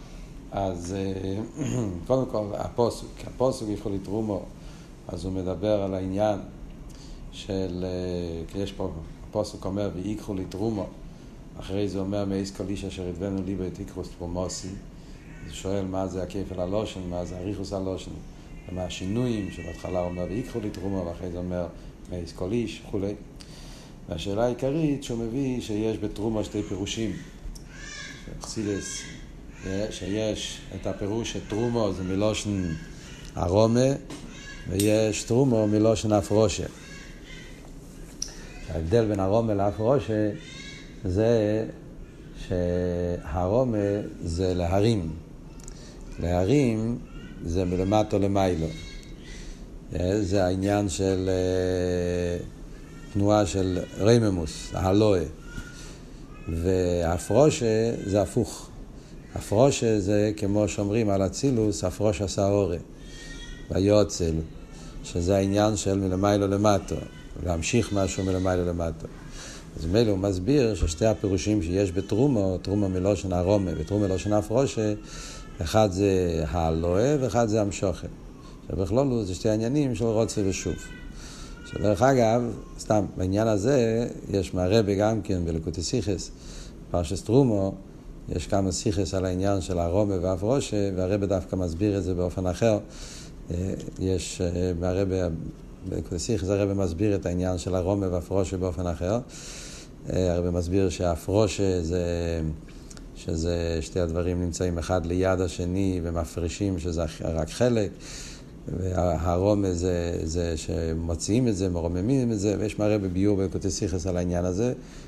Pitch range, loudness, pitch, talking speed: 90-105 Hz, -26 LUFS, 95 Hz, 115 wpm